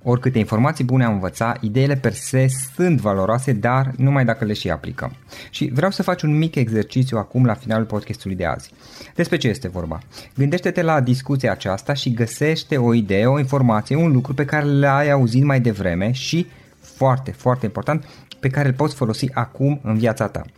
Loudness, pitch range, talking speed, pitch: -19 LUFS, 110-140 Hz, 185 wpm, 130 Hz